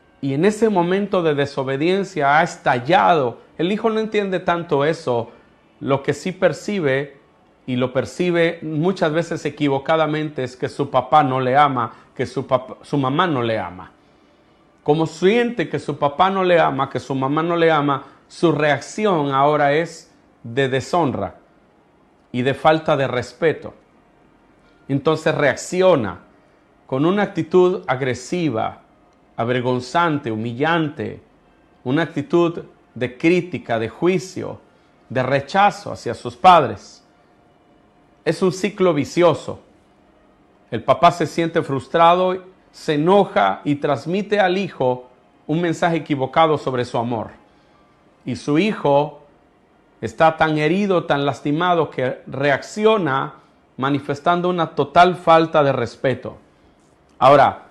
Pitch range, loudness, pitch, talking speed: 135-175 Hz, -19 LUFS, 150 Hz, 125 wpm